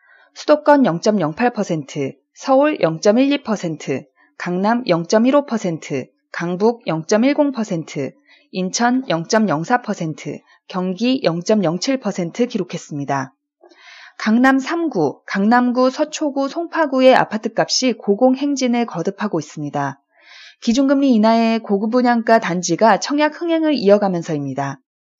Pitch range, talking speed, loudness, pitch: 175-265 Hz, 185 characters per minute, -18 LUFS, 220 Hz